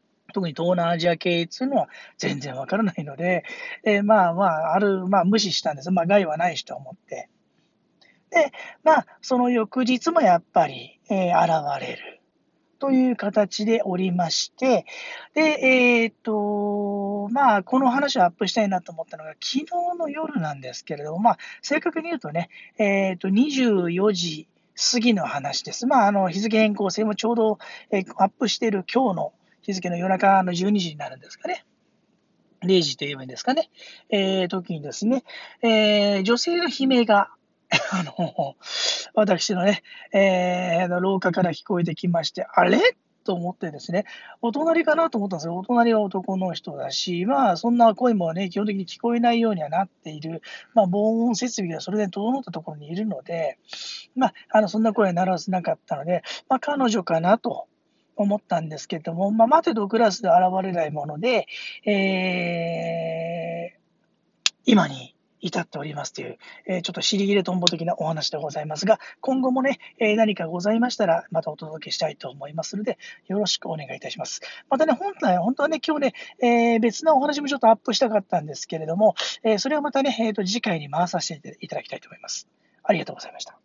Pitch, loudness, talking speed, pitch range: 205 Hz, -23 LUFS, 350 characters per minute, 180-240 Hz